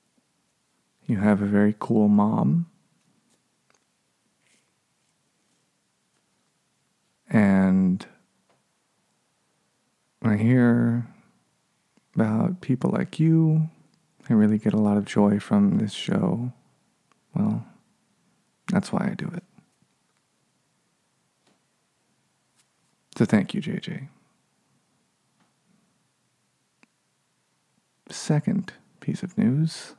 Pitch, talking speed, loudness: 160 Hz, 75 wpm, -23 LUFS